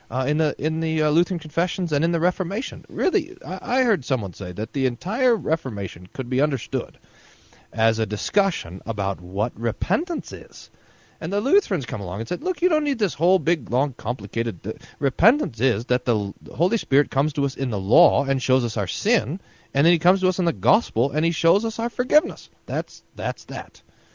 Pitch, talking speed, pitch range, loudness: 145 Hz, 210 wpm, 115-180 Hz, -23 LUFS